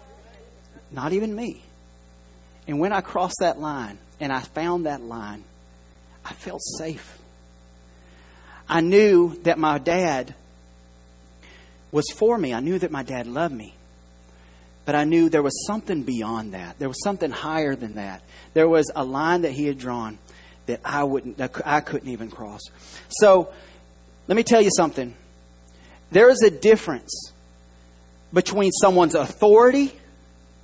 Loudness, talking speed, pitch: -21 LUFS, 145 wpm, 120 Hz